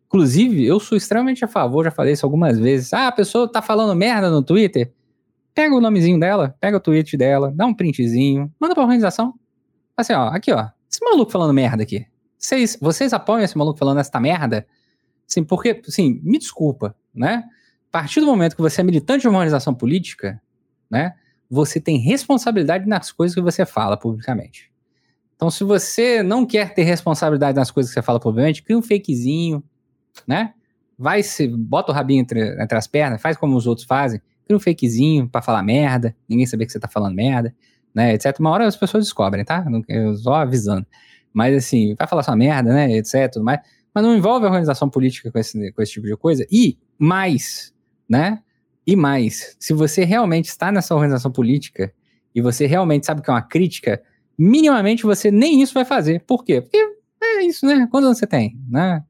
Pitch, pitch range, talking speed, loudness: 155 Hz, 125-205 Hz, 190 wpm, -18 LUFS